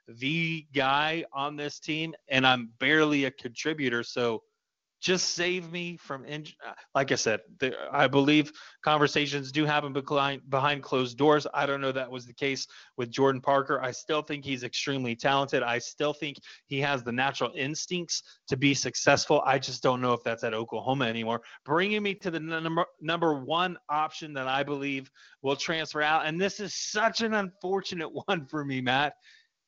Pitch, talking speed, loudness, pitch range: 145 Hz, 180 wpm, -28 LUFS, 135-160 Hz